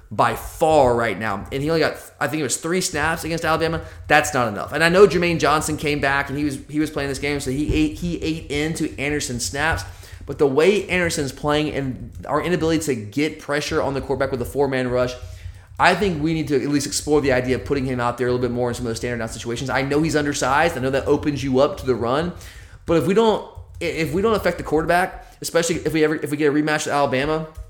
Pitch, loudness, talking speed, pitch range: 145 Hz, -21 LUFS, 260 wpm, 125-155 Hz